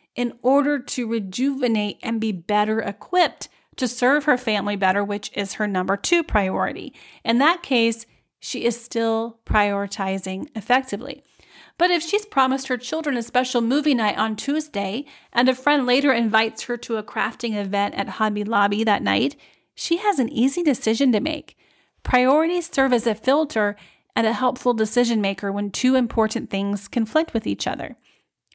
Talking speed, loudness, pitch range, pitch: 165 wpm, -22 LUFS, 210-265 Hz, 235 Hz